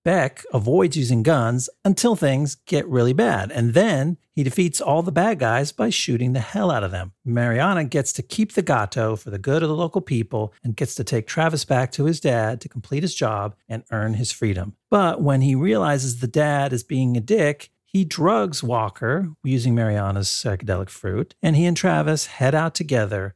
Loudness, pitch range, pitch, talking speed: -21 LUFS, 115-165 Hz, 135 Hz, 200 wpm